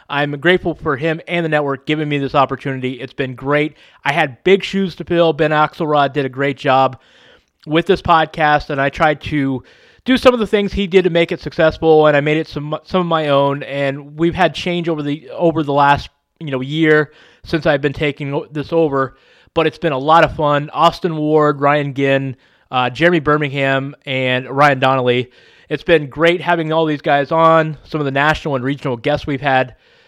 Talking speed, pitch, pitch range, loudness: 210 wpm, 150 Hz, 140-165 Hz, -16 LUFS